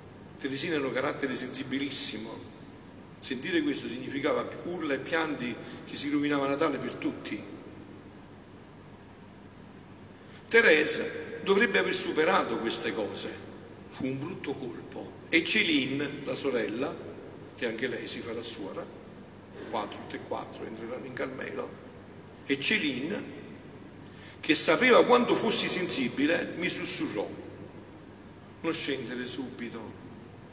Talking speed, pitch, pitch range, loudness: 115 wpm, 125 Hz, 100-140 Hz, -26 LUFS